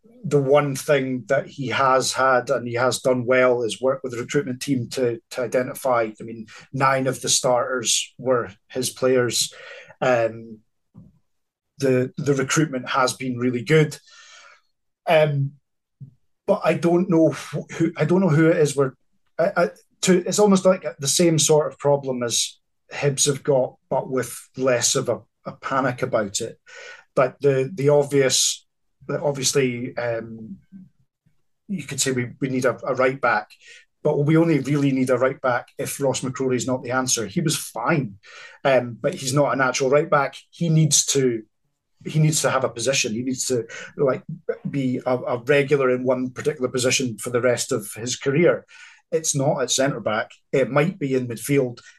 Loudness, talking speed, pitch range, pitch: -21 LUFS, 180 wpm, 125-155 Hz, 135 Hz